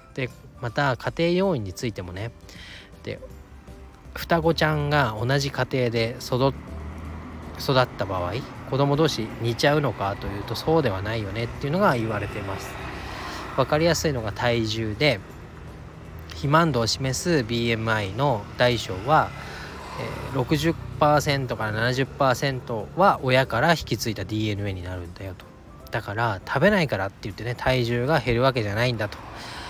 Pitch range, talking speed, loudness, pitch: 100-140 Hz, 280 characters per minute, -24 LUFS, 120 Hz